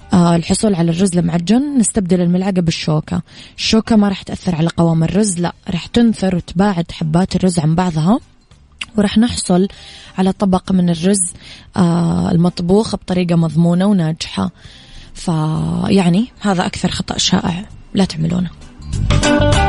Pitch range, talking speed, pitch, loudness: 170-200 Hz, 120 wpm, 180 Hz, -15 LUFS